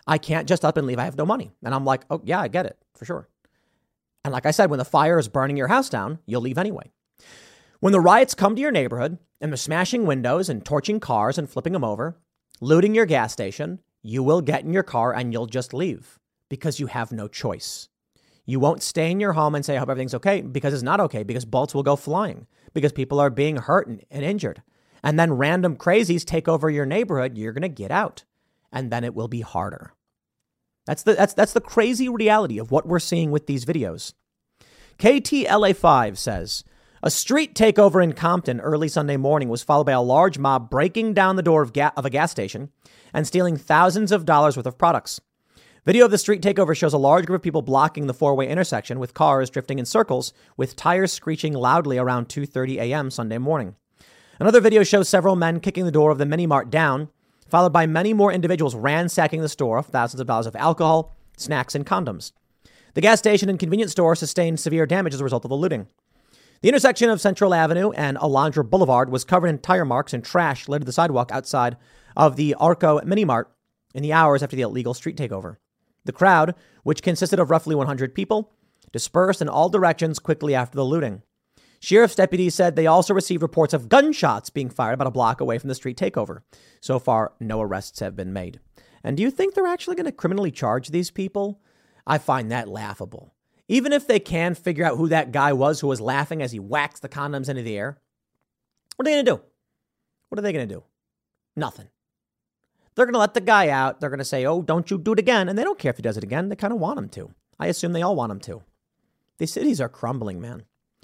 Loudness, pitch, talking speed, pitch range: -21 LUFS, 155 Hz, 220 wpm, 130-185 Hz